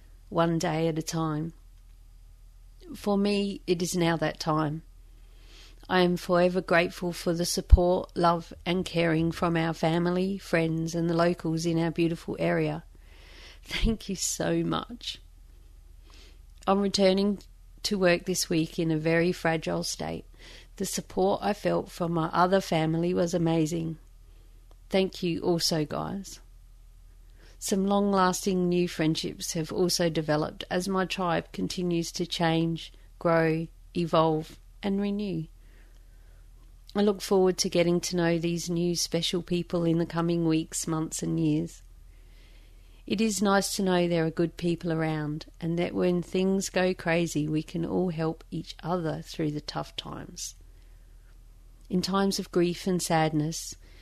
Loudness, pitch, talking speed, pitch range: -28 LUFS, 165 Hz, 145 wpm, 120-180 Hz